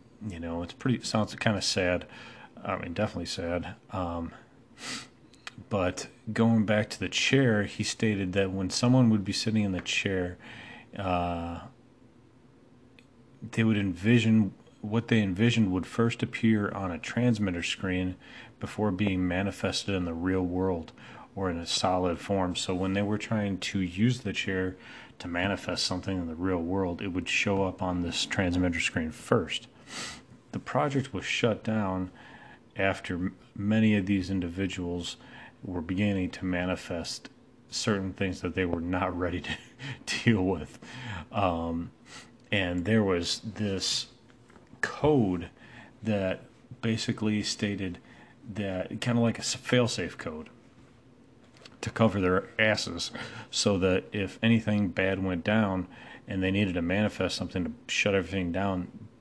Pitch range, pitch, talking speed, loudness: 90-115 Hz, 100 Hz, 145 wpm, -29 LUFS